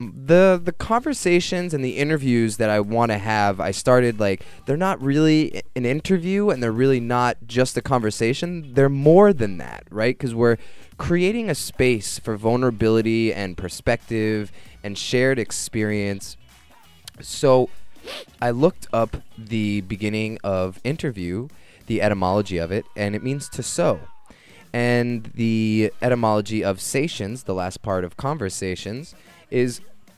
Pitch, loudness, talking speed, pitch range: 115 Hz, -21 LUFS, 140 wpm, 105-135 Hz